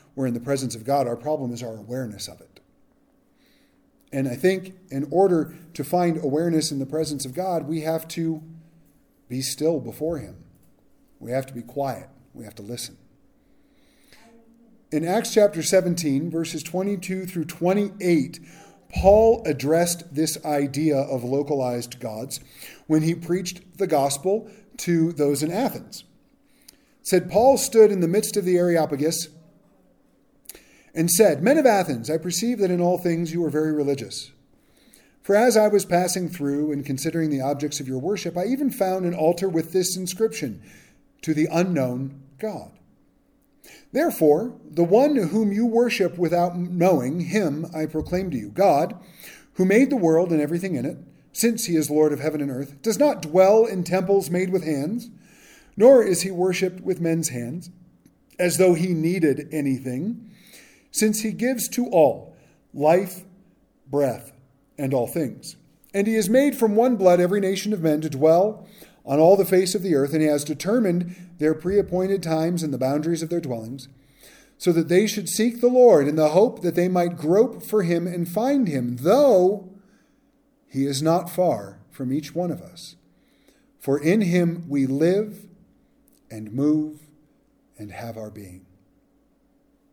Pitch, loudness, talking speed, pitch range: 170 Hz, -22 LUFS, 165 wpm, 145-200 Hz